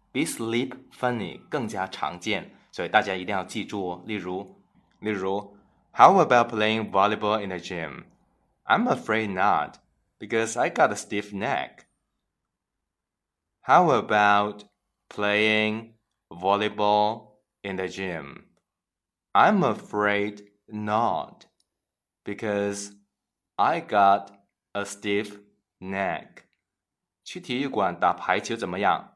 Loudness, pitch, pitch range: -25 LUFS, 105 Hz, 100-110 Hz